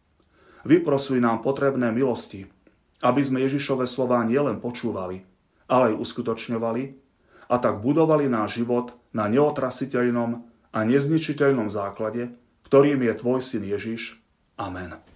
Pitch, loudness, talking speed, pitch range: 120 Hz, -24 LUFS, 115 wpm, 115-135 Hz